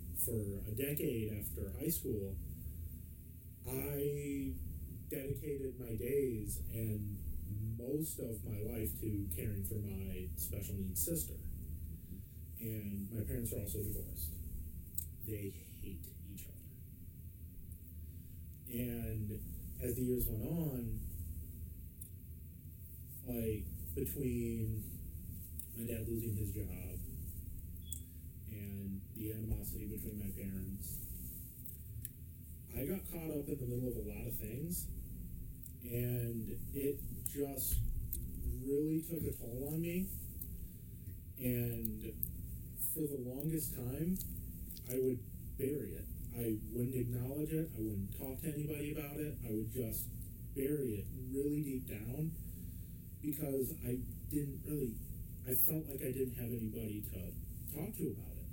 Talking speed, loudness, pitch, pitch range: 115 wpm, -42 LUFS, 105 Hz, 85-125 Hz